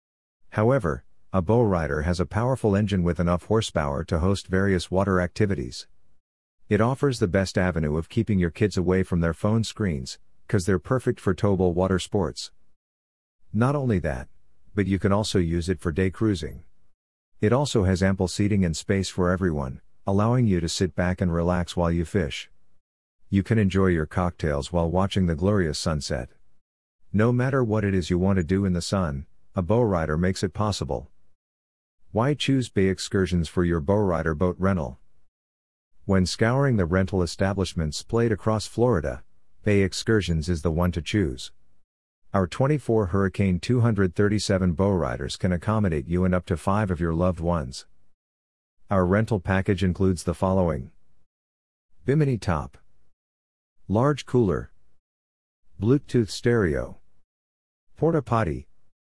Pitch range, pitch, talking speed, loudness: 80-100 Hz, 95 Hz, 155 wpm, -24 LUFS